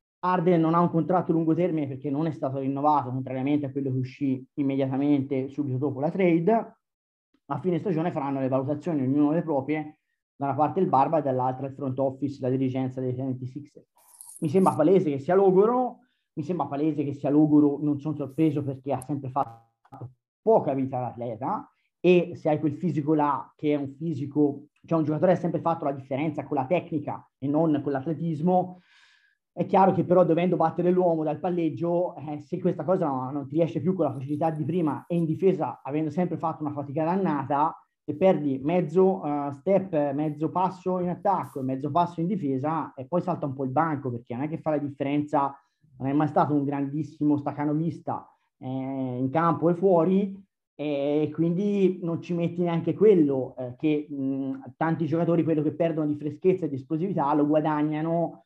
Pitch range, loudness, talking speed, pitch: 140-170 Hz, -26 LUFS, 195 wpm, 155 Hz